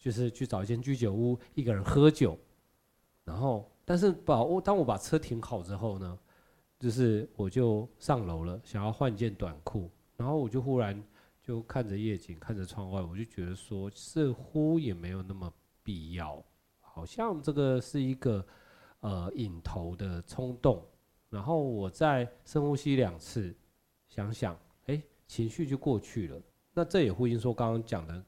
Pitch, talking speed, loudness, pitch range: 115 Hz, 240 characters per minute, -32 LUFS, 95-135 Hz